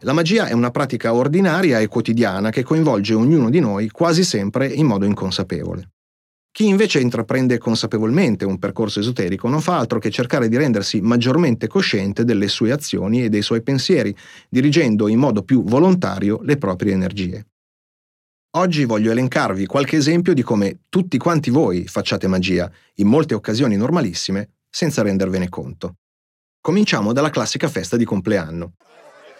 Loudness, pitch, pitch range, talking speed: -18 LUFS, 110 Hz, 100-135 Hz, 150 wpm